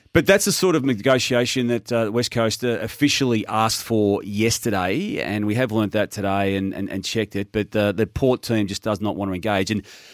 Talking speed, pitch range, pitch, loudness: 220 wpm, 100-120 Hz, 110 Hz, -21 LUFS